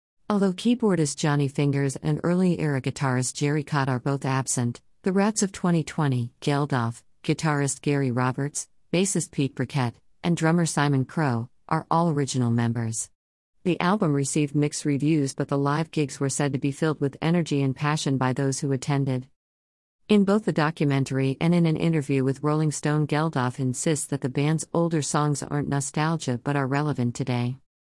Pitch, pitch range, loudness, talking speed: 145 Hz, 135-160 Hz, -25 LUFS, 165 wpm